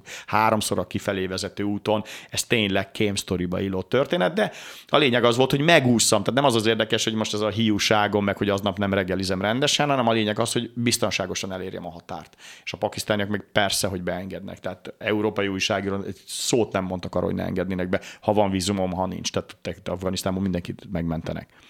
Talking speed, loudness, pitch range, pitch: 195 wpm, -23 LUFS, 95-110 Hz, 100 Hz